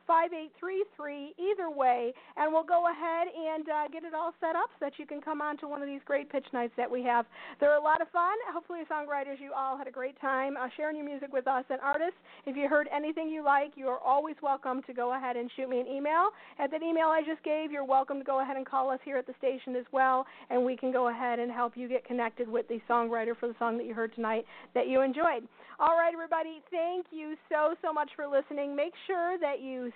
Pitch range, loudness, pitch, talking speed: 255-315 Hz, -32 LUFS, 280 Hz, 250 wpm